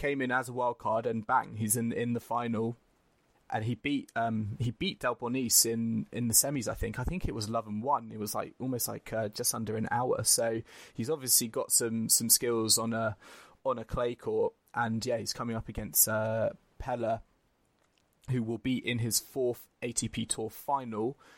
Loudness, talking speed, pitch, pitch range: -30 LUFS, 200 wpm, 115 Hz, 110-125 Hz